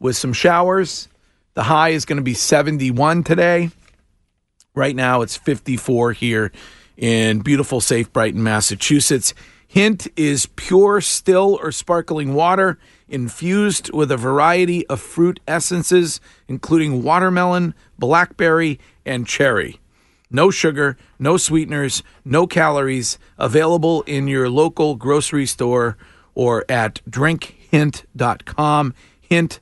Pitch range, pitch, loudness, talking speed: 125-165 Hz, 145 Hz, -17 LUFS, 115 wpm